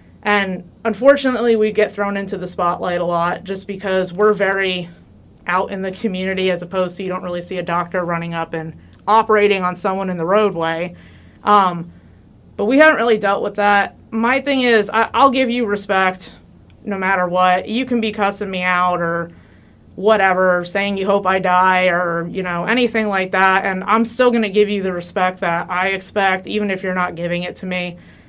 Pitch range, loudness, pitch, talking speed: 175-205 Hz, -17 LUFS, 190 Hz, 200 wpm